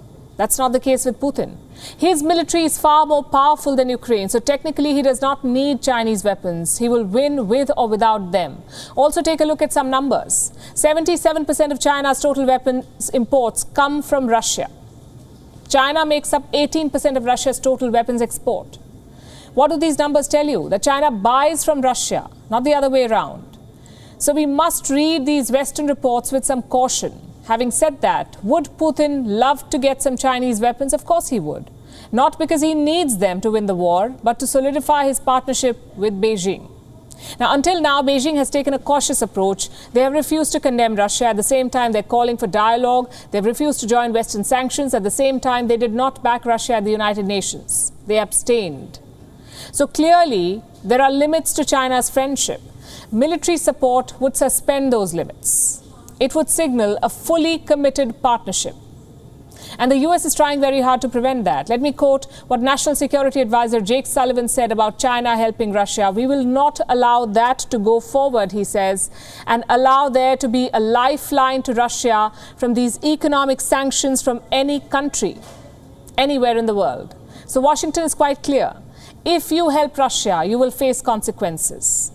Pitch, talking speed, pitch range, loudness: 260 Hz, 175 wpm, 235-290 Hz, -17 LUFS